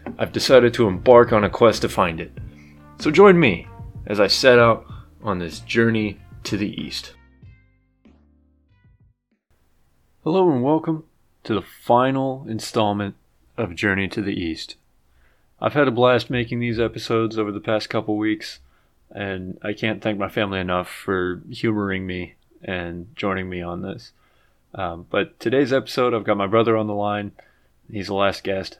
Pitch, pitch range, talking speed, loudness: 105 Hz, 90-115 Hz, 160 wpm, -20 LUFS